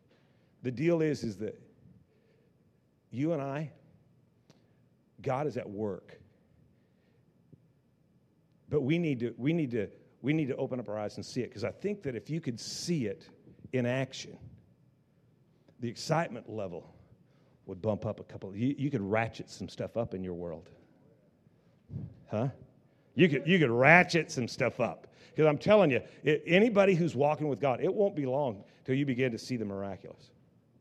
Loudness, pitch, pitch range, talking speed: -31 LUFS, 135 Hz, 120-155 Hz, 170 wpm